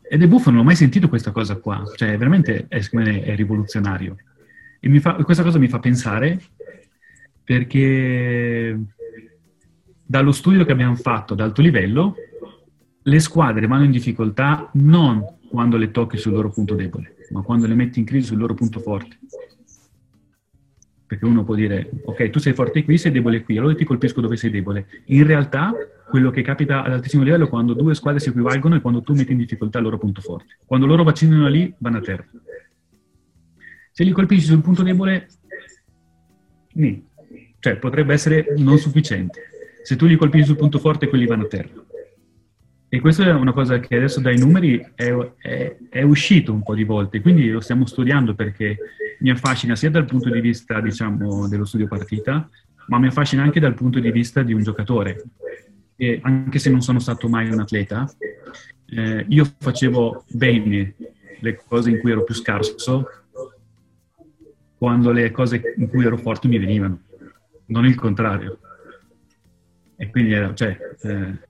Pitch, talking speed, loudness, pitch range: 120 Hz, 175 wpm, -18 LUFS, 110-145 Hz